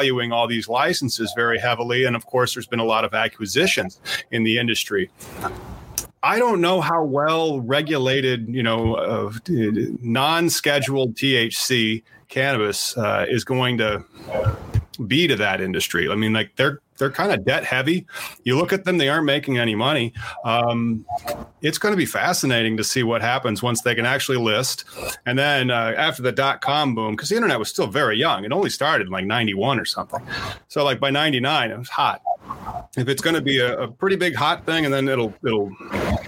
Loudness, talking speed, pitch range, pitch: -21 LUFS, 190 wpm, 115-140 Hz, 125 Hz